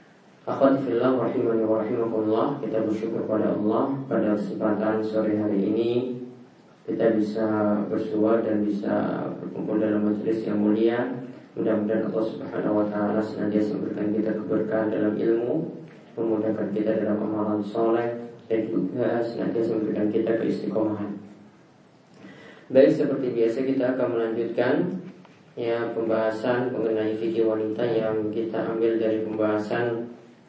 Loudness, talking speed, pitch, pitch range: -25 LUFS, 115 wpm, 110 Hz, 110-115 Hz